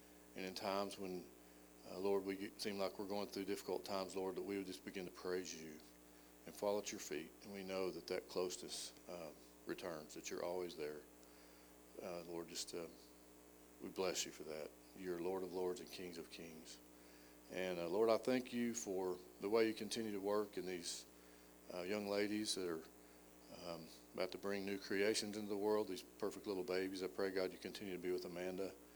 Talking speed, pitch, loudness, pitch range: 205 wpm, 90 Hz, -45 LUFS, 60-100 Hz